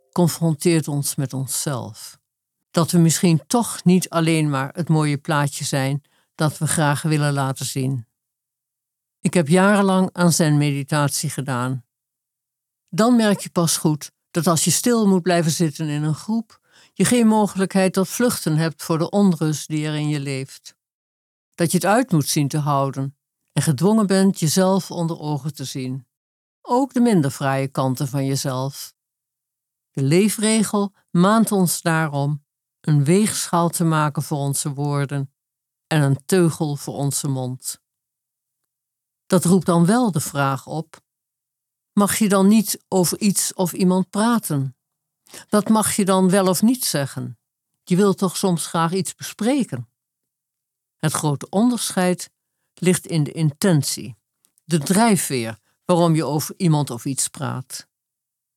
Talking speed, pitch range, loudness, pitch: 150 wpm, 135-185 Hz, -20 LUFS, 155 Hz